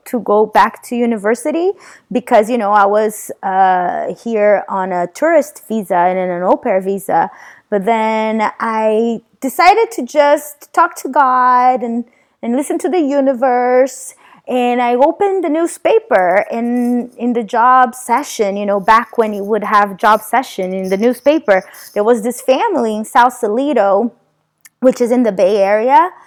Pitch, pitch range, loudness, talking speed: 240 Hz, 210-270 Hz, -14 LUFS, 160 wpm